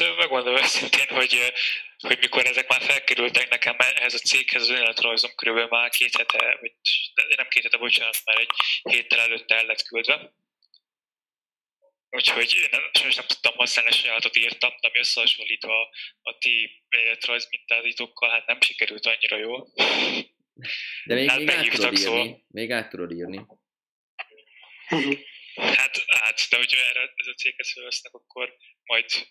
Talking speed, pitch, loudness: 145 wpm, 120 Hz, -21 LUFS